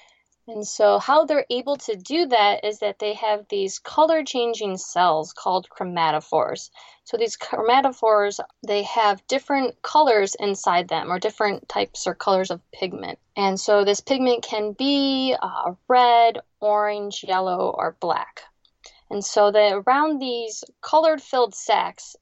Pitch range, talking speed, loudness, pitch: 200-265 Hz, 145 wpm, -21 LUFS, 215 Hz